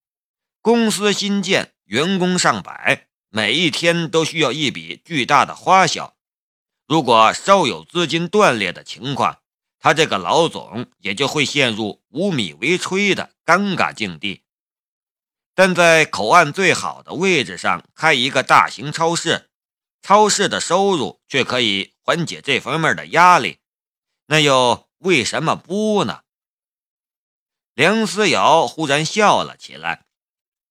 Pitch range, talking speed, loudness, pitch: 150-195 Hz, 195 characters per minute, -17 LUFS, 170 Hz